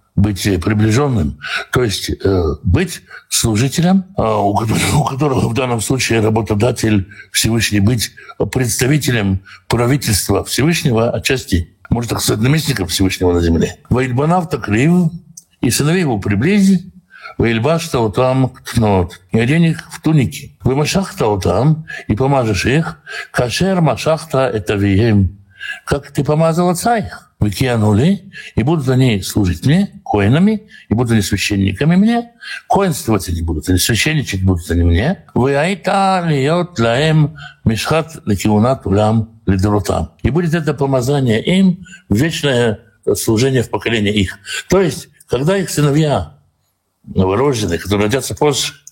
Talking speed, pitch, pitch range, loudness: 120 wpm, 125 Hz, 105-155 Hz, -15 LUFS